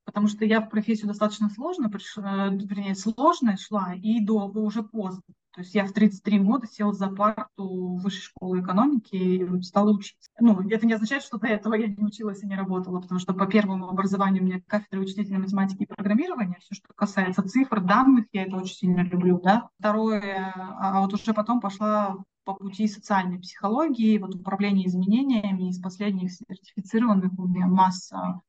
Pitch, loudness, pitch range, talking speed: 200 Hz, -25 LUFS, 190-215 Hz, 180 wpm